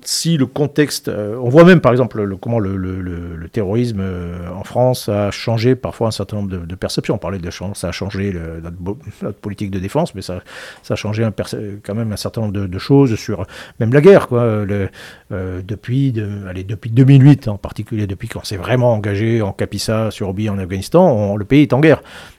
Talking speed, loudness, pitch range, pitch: 220 wpm, -16 LUFS, 95-120 Hz, 105 Hz